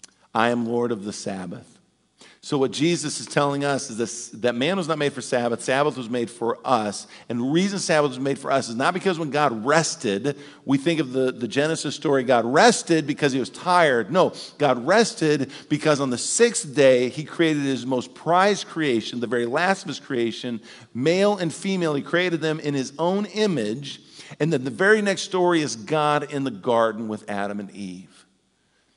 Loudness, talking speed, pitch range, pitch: -22 LUFS, 205 wpm, 120-160 Hz, 140 Hz